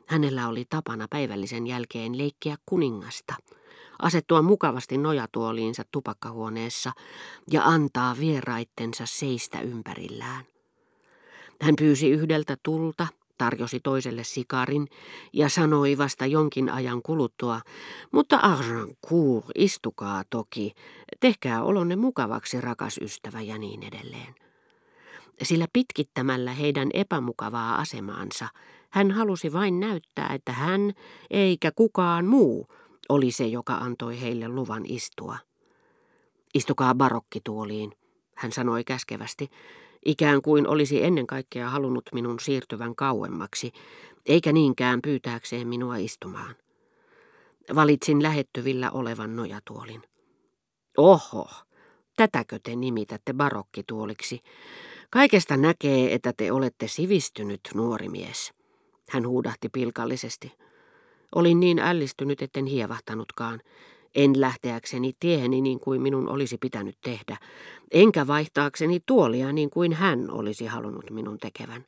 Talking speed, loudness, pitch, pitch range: 105 wpm, -26 LUFS, 130 Hz, 115-155 Hz